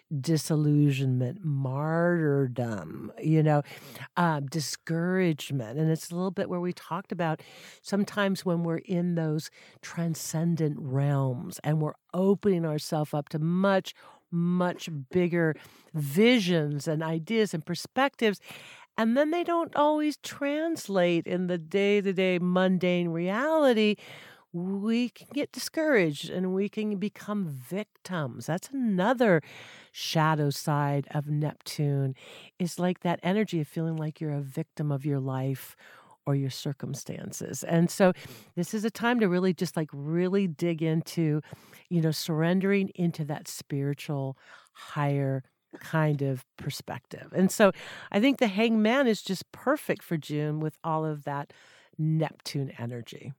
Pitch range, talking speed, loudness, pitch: 150-190 Hz, 135 wpm, -28 LUFS, 165 Hz